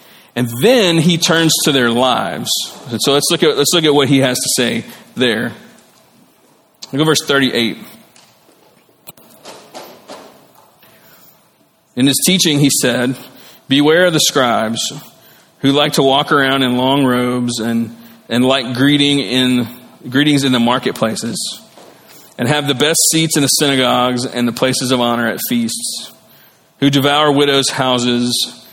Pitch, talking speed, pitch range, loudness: 135 Hz, 145 wpm, 125-150 Hz, -13 LUFS